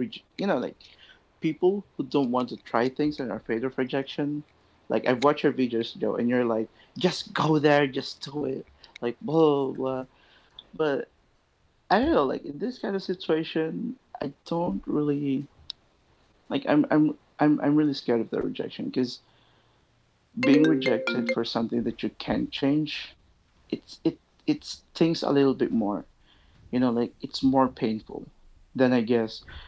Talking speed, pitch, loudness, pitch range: 170 wpm, 135 Hz, -27 LUFS, 120-150 Hz